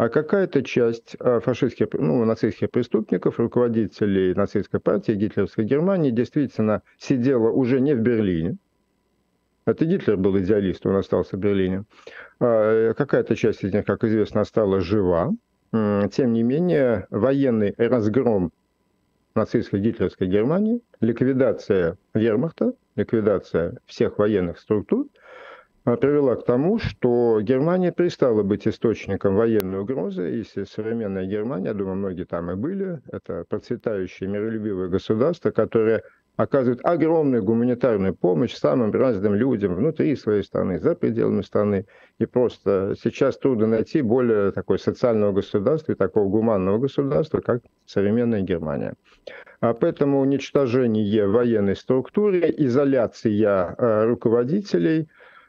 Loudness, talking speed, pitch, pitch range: -22 LUFS, 115 wpm, 115 Hz, 100-130 Hz